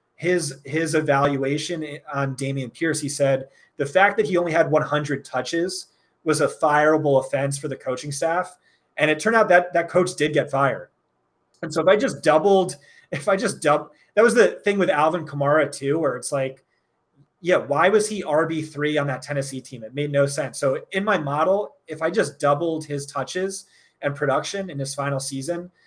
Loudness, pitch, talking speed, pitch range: -22 LUFS, 150 Hz, 195 wpm, 140-175 Hz